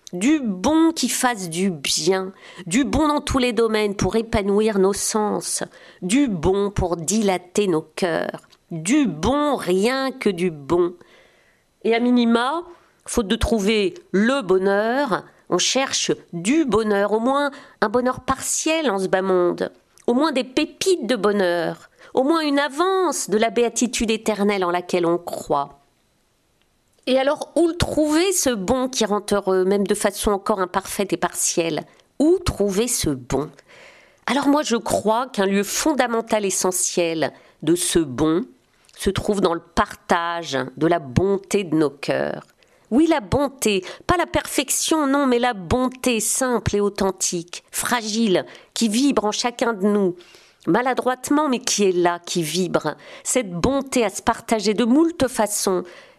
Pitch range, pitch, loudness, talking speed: 185-260 Hz, 215 Hz, -21 LUFS, 155 wpm